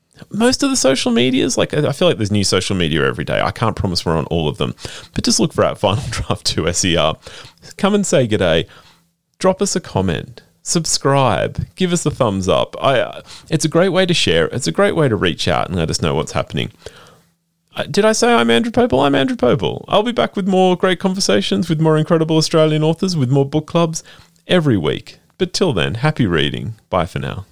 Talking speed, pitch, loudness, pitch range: 225 wpm, 155 Hz, -16 LUFS, 120-185 Hz